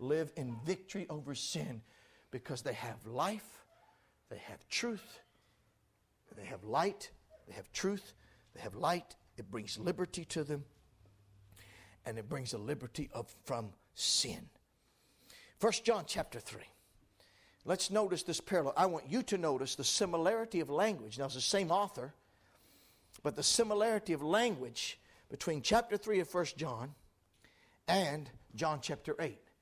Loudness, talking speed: -36 LUFS, 145 wpm